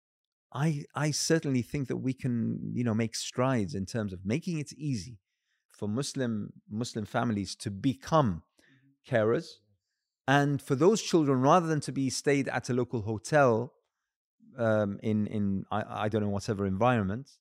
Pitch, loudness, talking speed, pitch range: 125 Hz, -30 LUFS, 160 wpm, 105-140 Hz